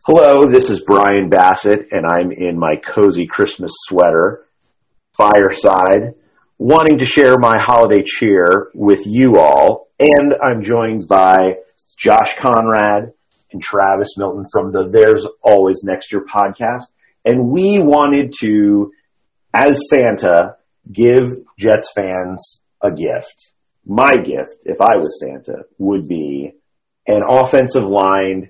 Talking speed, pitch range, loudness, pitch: 125 wpm, 95-130 Hz, -12 LUFS, 105 Hz